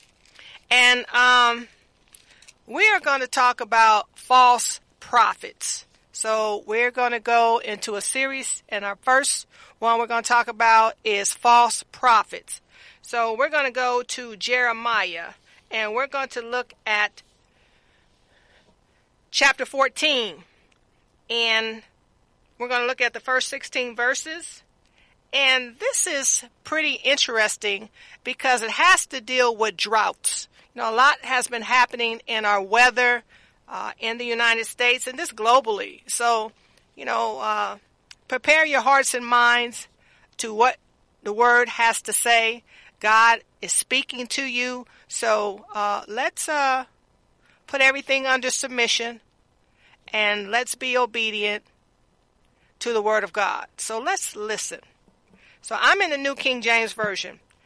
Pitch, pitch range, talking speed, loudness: 240 Hz, 225-260 Hz, 140 wpm, -21 LUFS